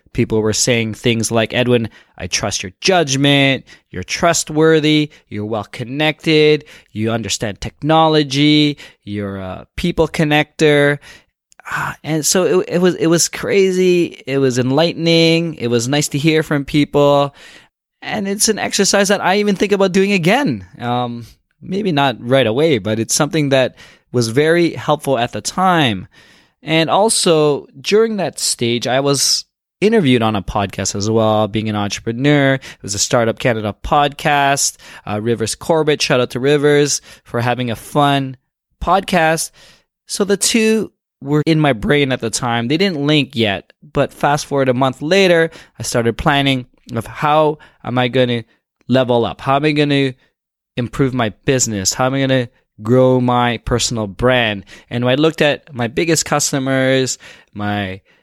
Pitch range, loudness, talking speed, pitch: 120-155 Hz, -15 LUFS, 160 wpm, 135 Hz